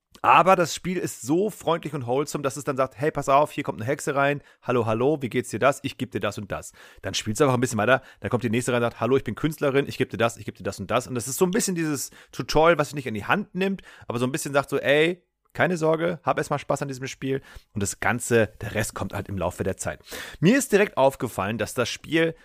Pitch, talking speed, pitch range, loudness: 135 Hz, 290 wpm, 115-155 Hz, -24 LUFS